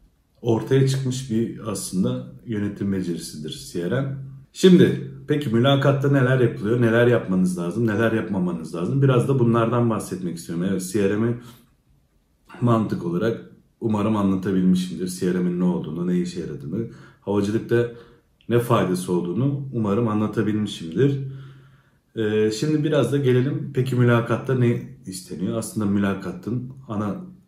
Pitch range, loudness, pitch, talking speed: 95-130 Hz, -22 LUFS, 115 Hz, 120 wpm